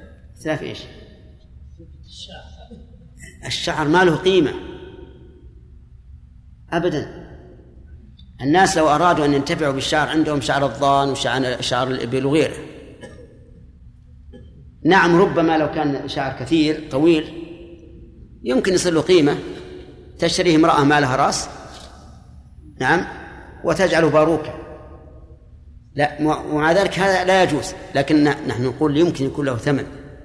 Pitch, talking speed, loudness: 145 Hz, 100 wpm, -18 LUFS